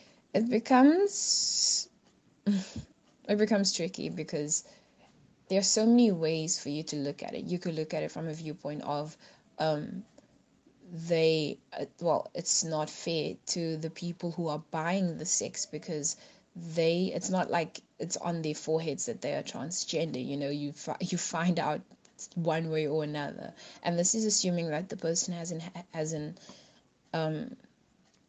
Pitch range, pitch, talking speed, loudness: 155-185 Hz, 165 Hz, 160 wpm, -31 LUFS